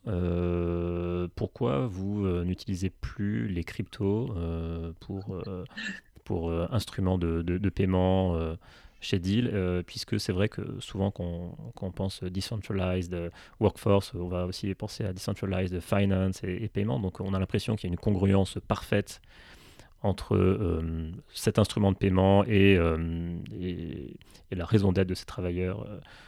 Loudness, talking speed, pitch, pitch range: -29 LUFS, 160 wpm, 95 Hz, 90-100 Hz